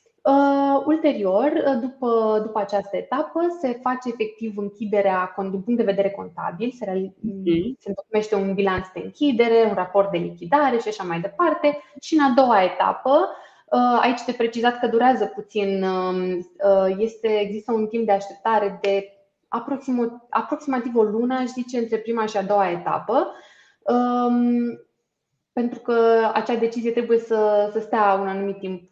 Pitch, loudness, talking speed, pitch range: 225 Hz, -22 LUFS, 155 wpm, 200-245 Hz